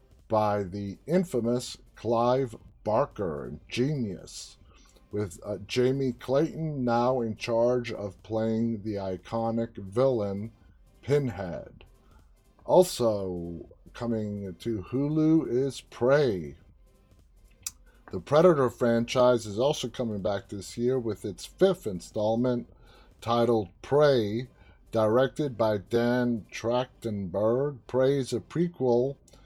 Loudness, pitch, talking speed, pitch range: -28 LUFS, 115 Hz, 100 wpm, 105-125 Hz